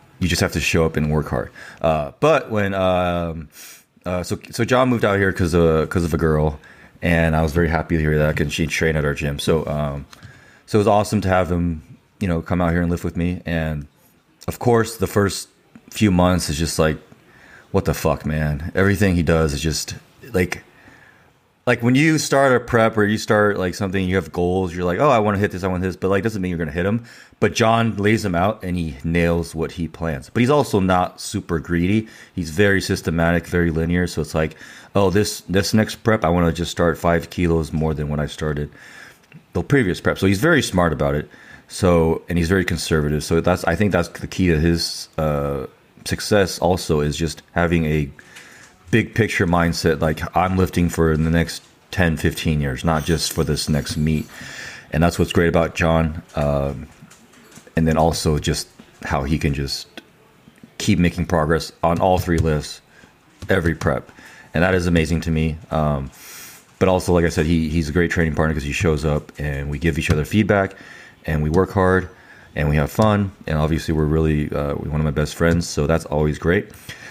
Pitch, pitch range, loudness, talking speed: 85 Hz, 80-95 Hz, -20 LUFS, 215 wpm